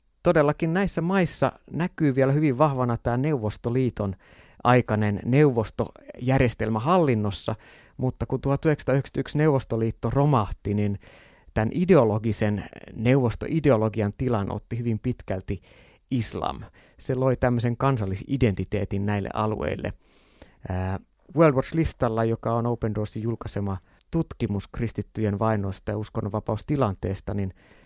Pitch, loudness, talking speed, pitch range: 115 Hz, -25 LUFS, 95 wpm, 105-135 Hz